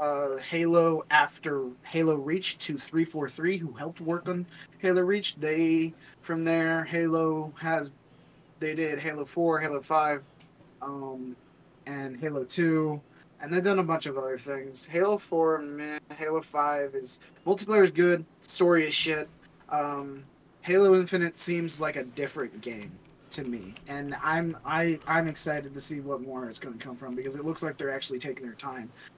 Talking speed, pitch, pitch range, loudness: 170 wpm, 155 Hz, 140-165 Hz, -28 LUFS